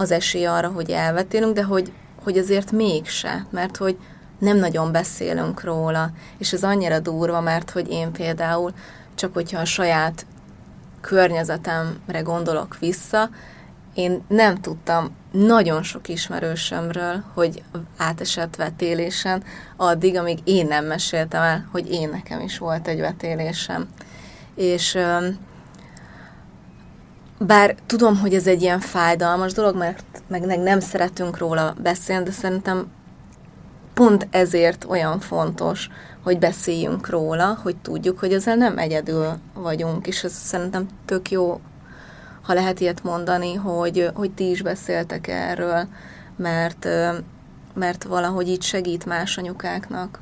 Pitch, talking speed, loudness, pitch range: 175 Hz, 125 wpm, -21 LUFS, 165-185 Hz